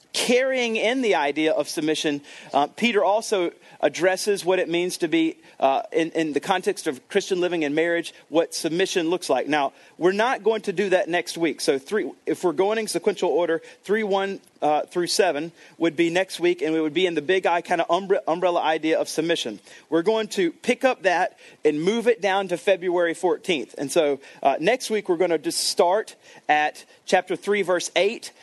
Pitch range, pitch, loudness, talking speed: 160-205 Hz, 180 Hz, -23 LUFS, 205 wpm